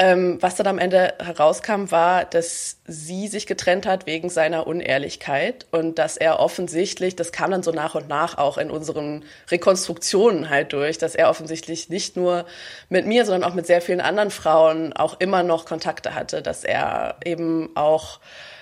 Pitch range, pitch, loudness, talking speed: 160-185 Hz, 170 Hz, -21 LUFS, 175 wpm